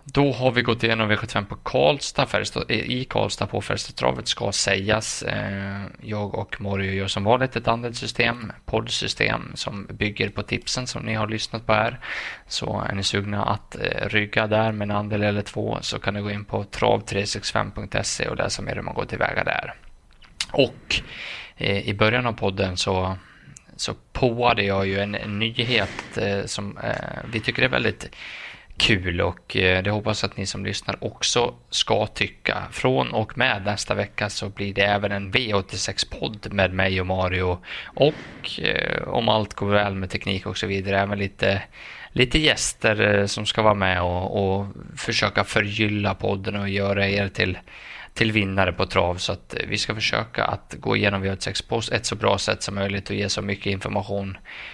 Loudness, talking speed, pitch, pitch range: -23 LUFS, 175 wpm, 105 Hz, 100-110 Hz